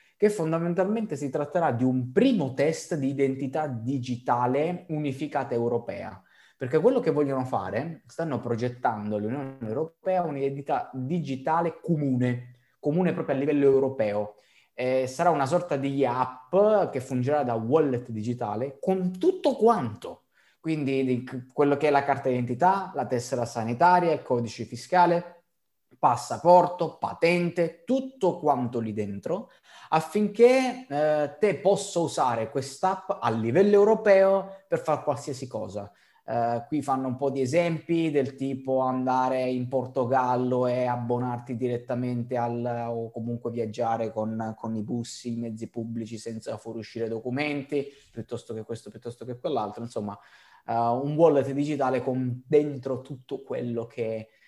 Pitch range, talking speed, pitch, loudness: 120-160 Hz, 135 wpm, 135 Hz, -26 LUFS